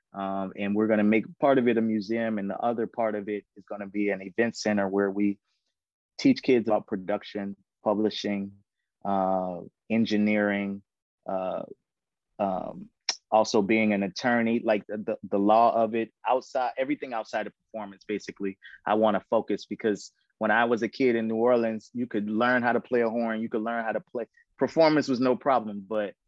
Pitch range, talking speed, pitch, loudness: 100-115 Hz, 190 wpm, 110 Hz, -27 LUFS